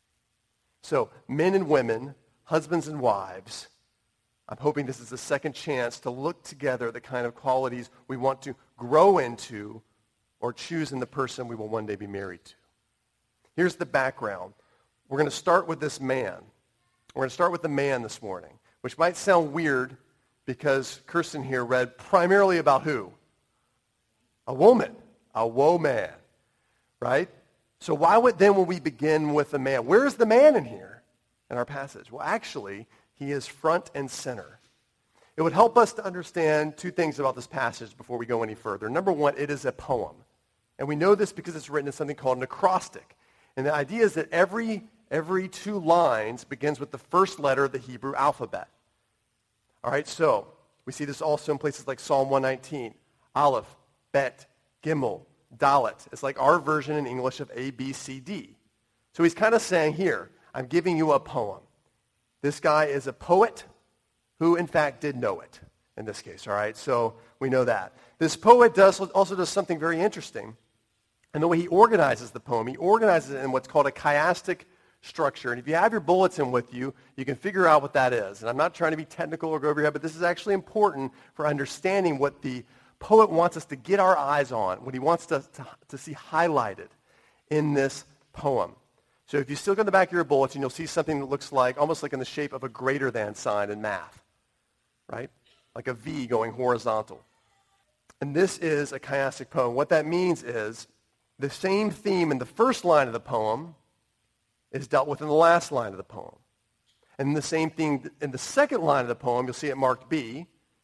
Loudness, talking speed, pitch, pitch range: -25 LUFS, 200 wpm, 145 Hz, 125-165 Hz